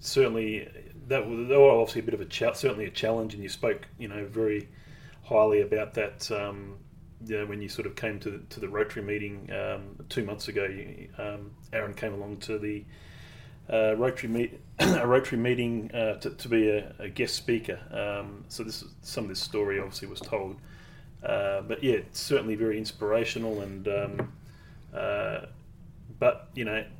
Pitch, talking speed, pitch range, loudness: 110 Hz, 185 wpm, 105-120 Hz, -29 LUFS